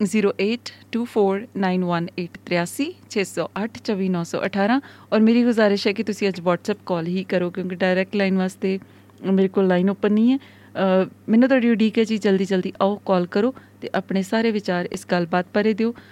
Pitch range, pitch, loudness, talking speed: 185-220 Hz, 195 Hz, -21 LUFS, 145 wpm